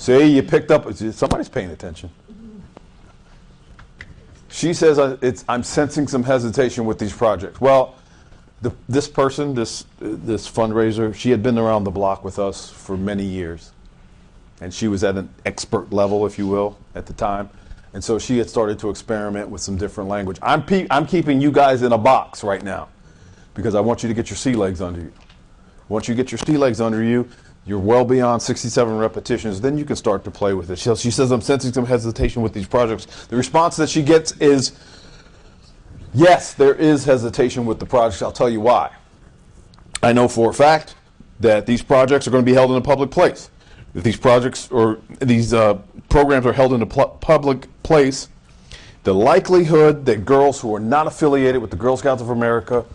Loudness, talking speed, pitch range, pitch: -18 LUFS, 195 wpm, 105-135 Hz, 120 Hz